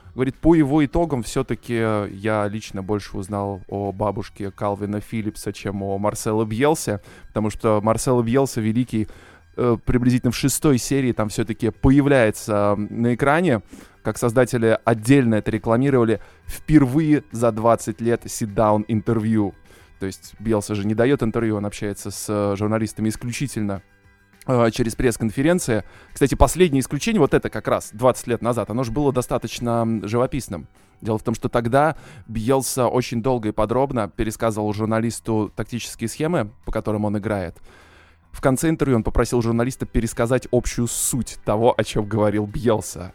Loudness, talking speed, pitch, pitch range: -21 LUFS, 145 wpm, 115 Hz, 105-125 Hz